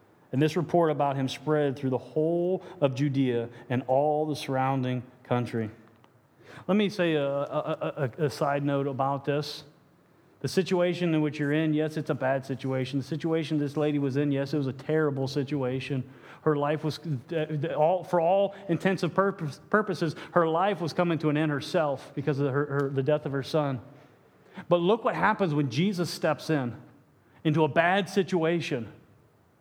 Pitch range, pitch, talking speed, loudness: 135-165 Hz, 150 Hz, 175 wpm, -28 LUFS